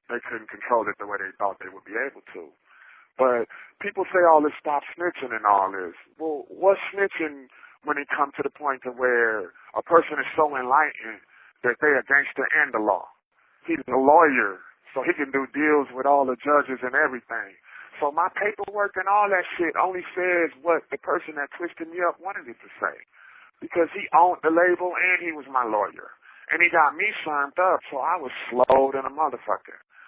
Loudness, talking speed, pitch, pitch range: -23 LUFS, 205 wpm, 160 Hz, 135-180 Hz